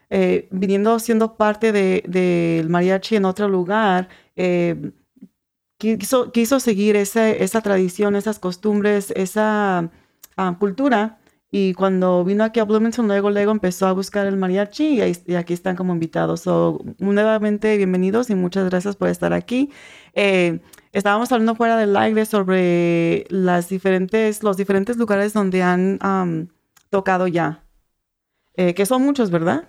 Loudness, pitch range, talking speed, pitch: -19 LUFS, 180-215 Hz, 150 wpm, 195 Hz